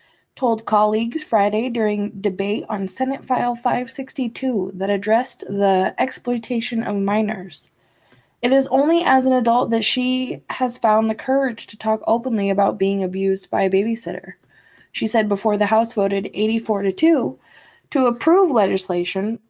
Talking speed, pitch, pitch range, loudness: 150 wpm, 220 Hz, 200-250 Hz, -20 LUFS